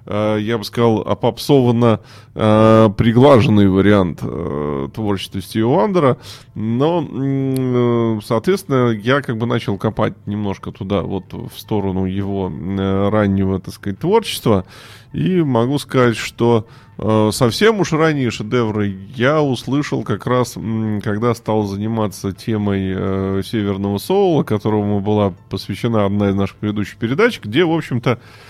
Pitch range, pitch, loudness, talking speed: 100-125 Hz, 110 Hz, -17 LUFS, 130 wpm